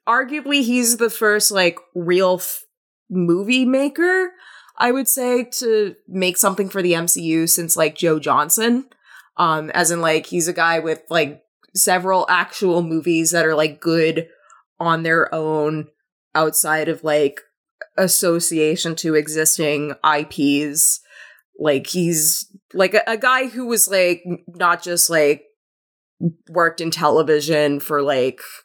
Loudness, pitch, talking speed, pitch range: -18 LUFS, 170 Hz, 135 wpm, 155-210 Hz